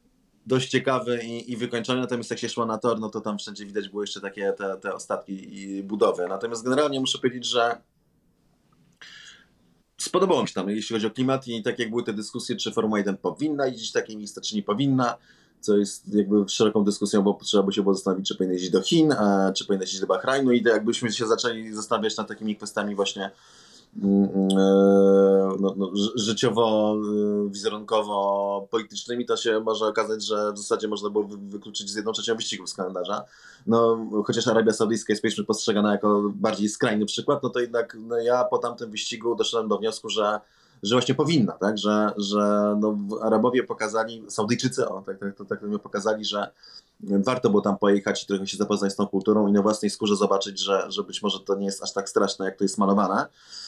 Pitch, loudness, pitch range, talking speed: 105 Hz, -24 LUFS, 100-115 Hz, 195 wpm